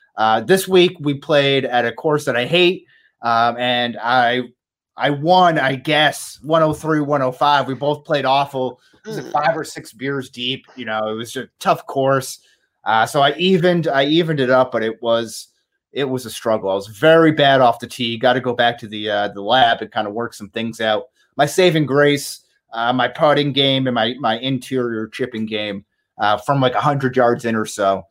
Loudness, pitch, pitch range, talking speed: -17 LUFS, 130 Hz, 115-145 Hz, 220 wpm